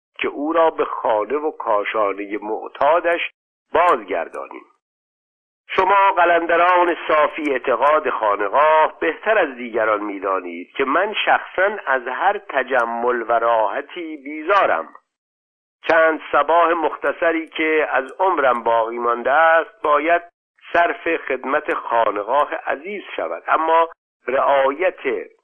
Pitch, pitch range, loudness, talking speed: 160 Hz, 120-175 Hz, -18 LUFS, 105 wpm